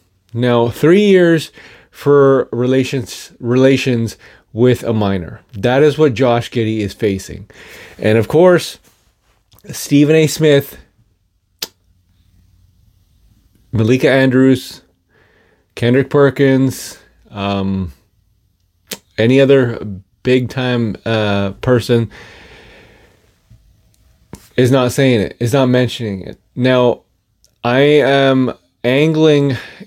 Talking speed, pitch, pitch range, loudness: 90 wpm, 120 Hz, 100-130 Hz, -14 LUFS